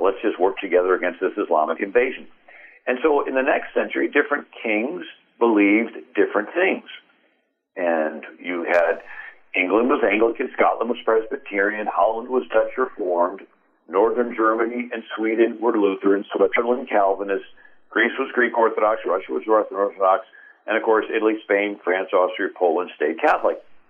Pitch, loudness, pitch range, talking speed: 110 Hz, -21 LUFS, 100-120 Hz, 145 wpm